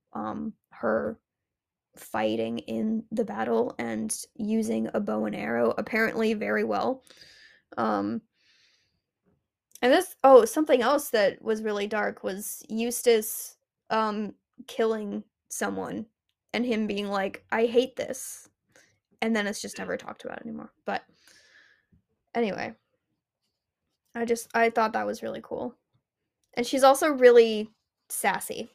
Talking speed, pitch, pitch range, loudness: 125 wpm, 225 Hz, 210-245 Hz, -26 LUFS